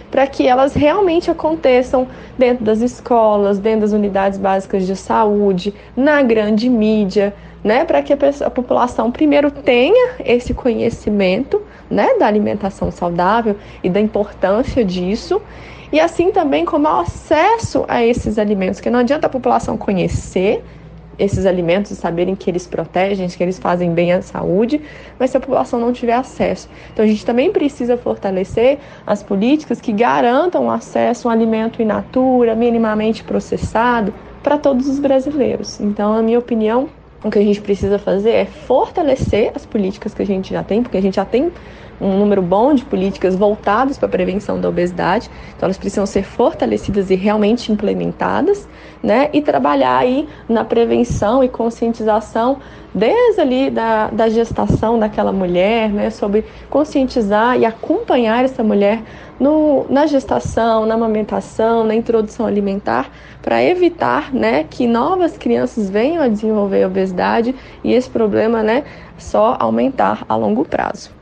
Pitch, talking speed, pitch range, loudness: 225 Hz, 155 wpm, 205-260 Hz, -16 LUFS